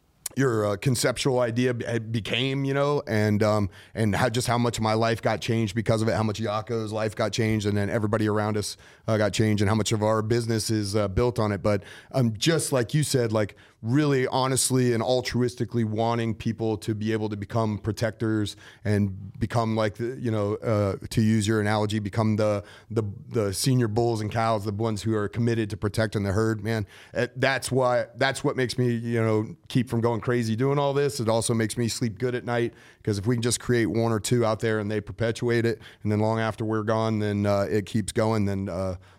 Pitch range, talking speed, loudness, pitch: 105-120 Hz, 225 wpm, -25 LUFS, 110 Hz